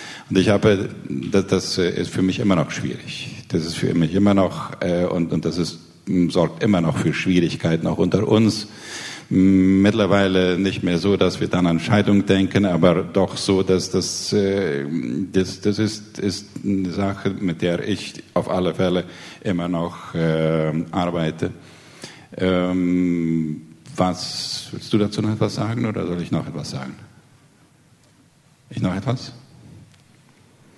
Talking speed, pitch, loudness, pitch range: 155 wpm, 95 Hz, -21 LUFS, 90-100 Hz